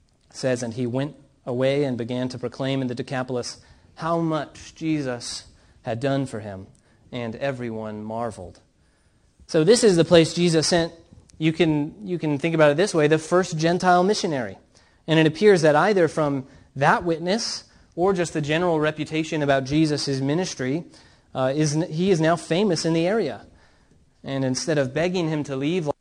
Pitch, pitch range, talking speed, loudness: 150 Hz, 130-165 Hz, 175 wpm, -22 LUFS